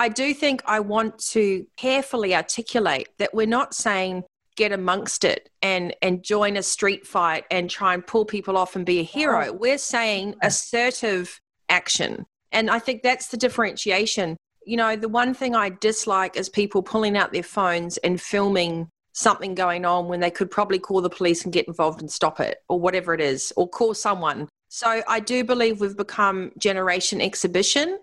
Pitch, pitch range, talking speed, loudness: 200 Hz, 180-230 Hz, 185 wpm, -22 LUFS